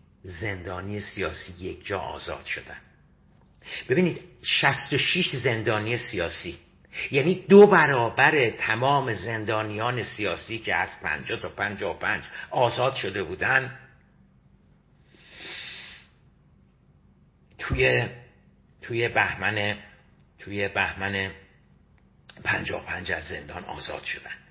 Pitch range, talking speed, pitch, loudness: 100-135 Hz, 85 wpm, 110 Hz, -25 LUFS